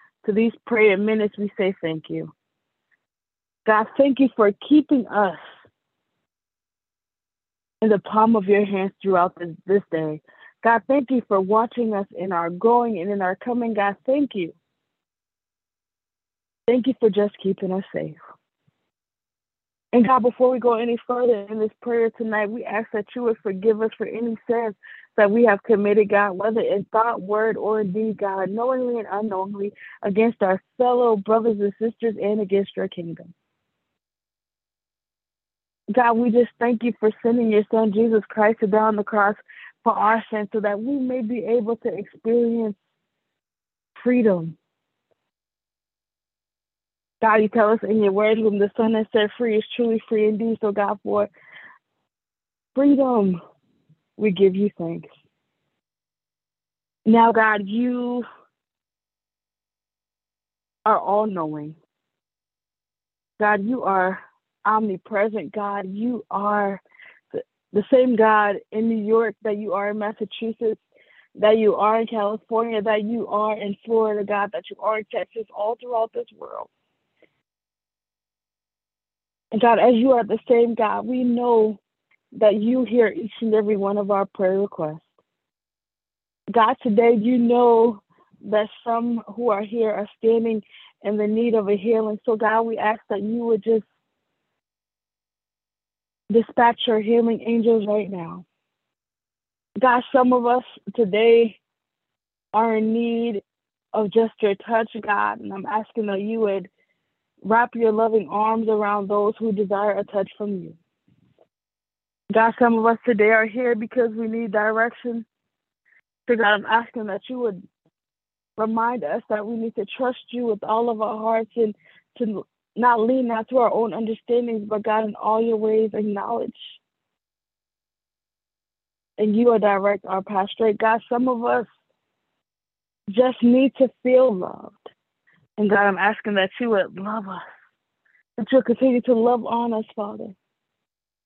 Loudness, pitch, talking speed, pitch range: -21 LUFS, 220 Hz, 150 wpm, 205-230 Hz